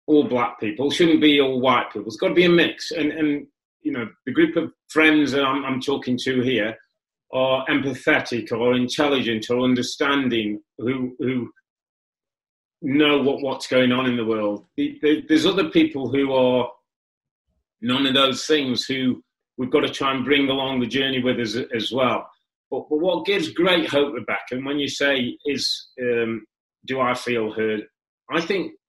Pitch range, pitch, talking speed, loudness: 125-150 Hz, 135 Hz, 185 wpm, -21 LUFS